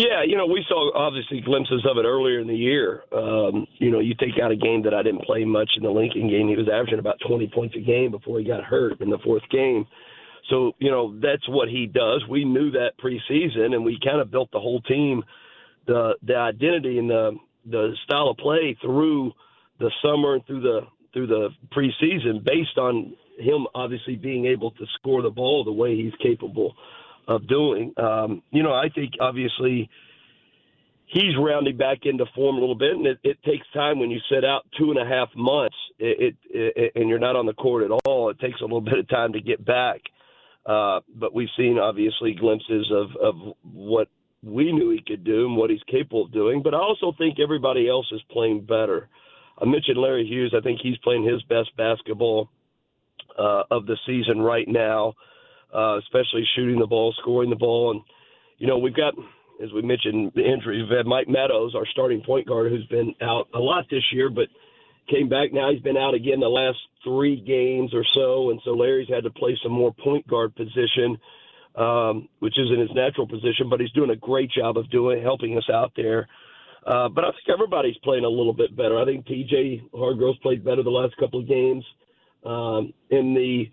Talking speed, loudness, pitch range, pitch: 210 wpm, -23 LUFS, 115-145 Hz, 125 Hz